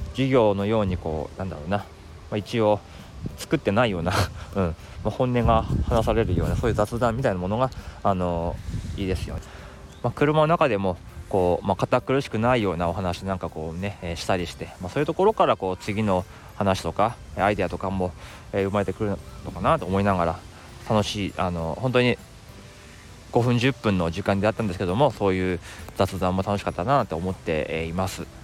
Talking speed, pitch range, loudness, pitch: 370 characters per minute, 90-110 Hz, -25 LUFS, 100 Hz